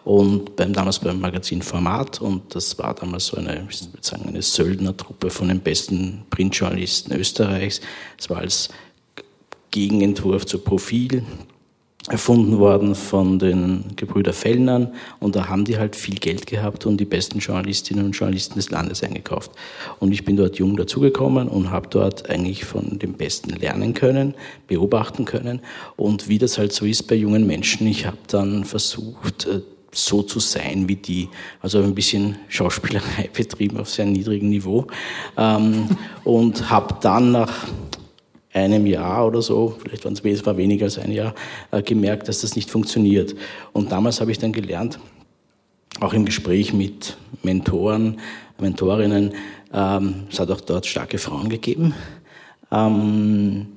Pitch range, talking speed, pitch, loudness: 95-110 Hz, 150 wpm, 100 Hz, -20 LUFS